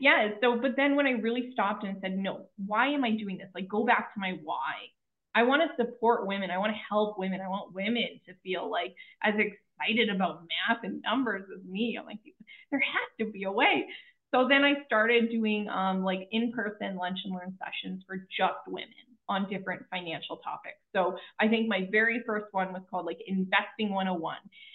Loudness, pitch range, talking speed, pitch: -29 LUFS, 190-235 Hz, 205 wpm, 210 Hz